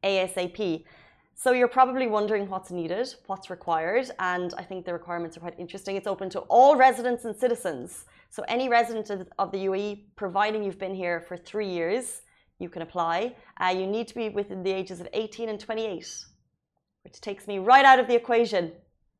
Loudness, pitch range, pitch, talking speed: -26 LUFS, 180-230 Hz, 195 Hz, 190 wpm